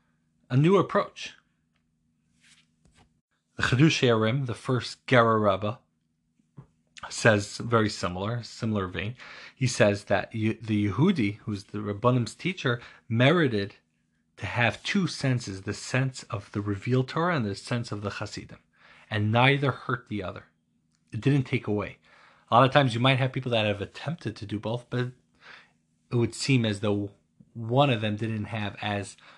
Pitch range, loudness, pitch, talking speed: 100-125 Hz, -26 LUFS, 110 Hz, 155 wpm